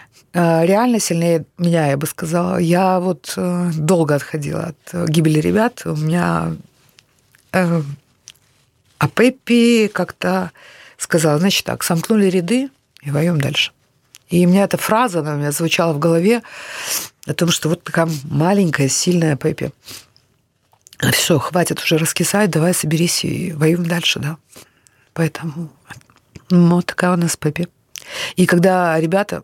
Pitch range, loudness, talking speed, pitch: 150-180 Hz, -17 LUFS, 135 wpm, 170 Hz